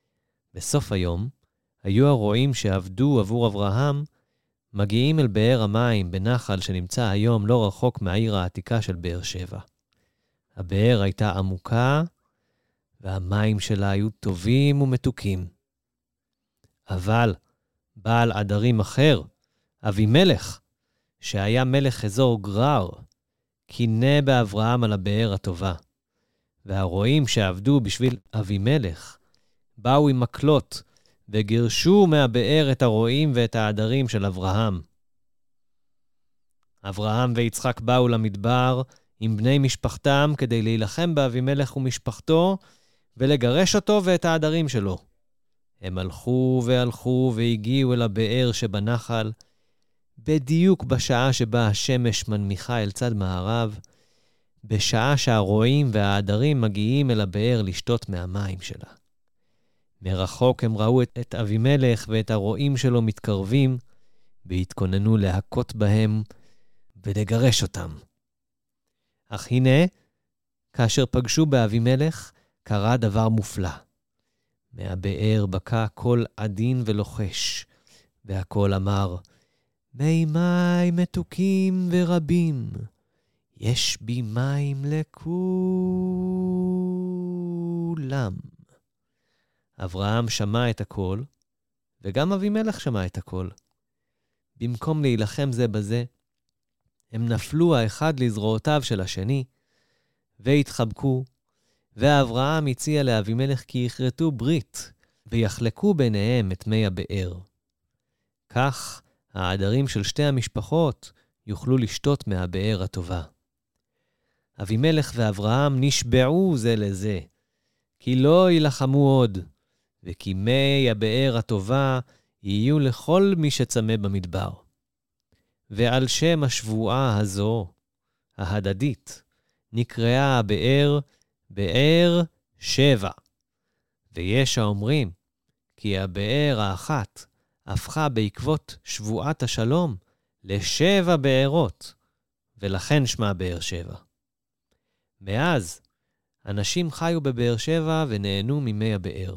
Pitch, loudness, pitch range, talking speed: 115 Hz, -23 LUFS, 100-135 Hz, 90 wpm